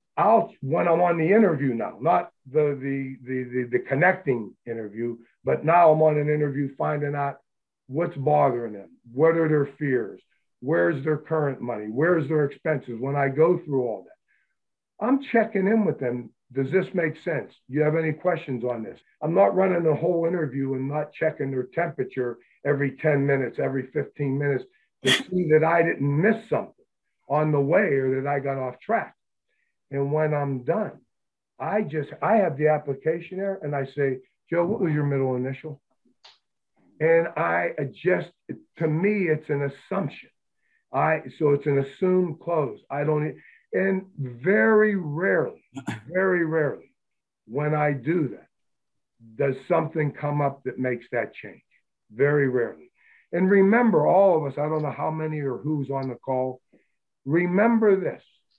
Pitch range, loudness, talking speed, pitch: 135-170 Hz, -24 LUFS, 170 wpm, 150 Hz